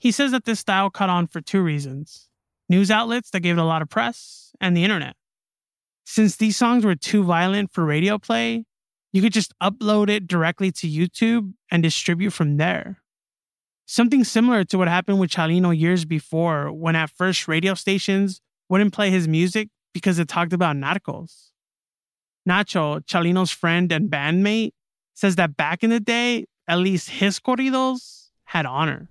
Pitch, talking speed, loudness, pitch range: 185 Hz, 170 wpm, -21 LUFS, 170-210 Hz